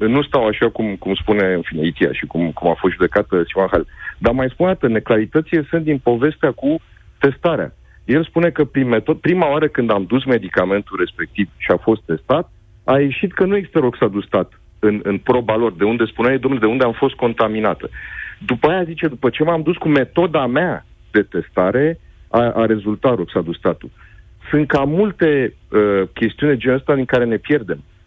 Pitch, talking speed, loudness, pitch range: 120 Hz, 190 wpm, -17 LUFS, 105-150 Hz